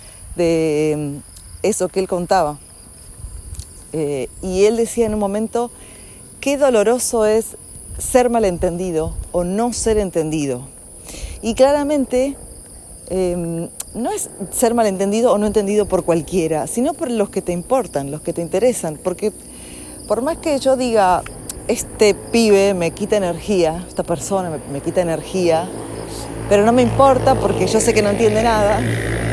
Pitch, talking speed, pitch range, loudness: 190 Hz, 145 wpm, 165-225 Hz, -18 LUFS